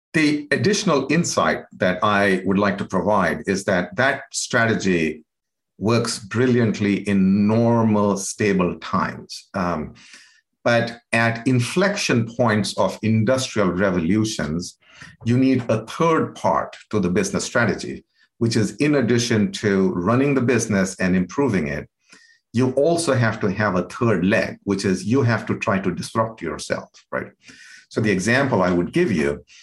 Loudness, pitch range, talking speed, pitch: -20 LUFS, 100-130 Hz, 145 wpm, 115 Hz